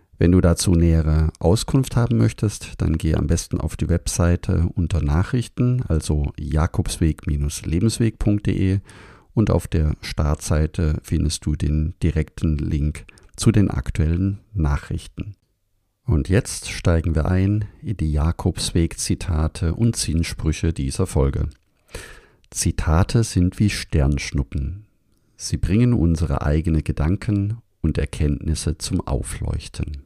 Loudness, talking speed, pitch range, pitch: -21 LUFS, 110 wpm, 80-100 Hz, 85 Hz